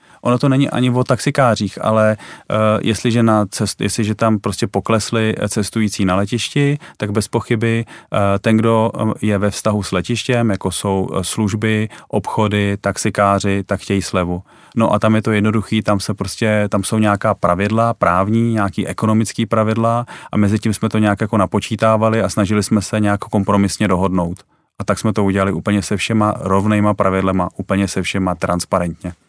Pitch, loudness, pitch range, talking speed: 105 Hz, -17 LUFS, 100-110 Hz, 170 wpm